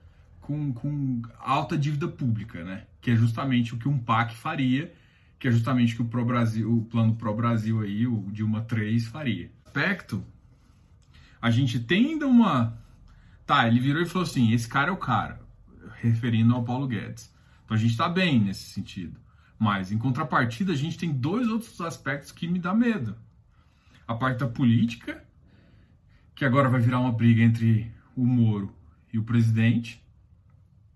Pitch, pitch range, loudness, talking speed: 120 Hz, 110-135 Hz, -25 LUFS, 165 wpm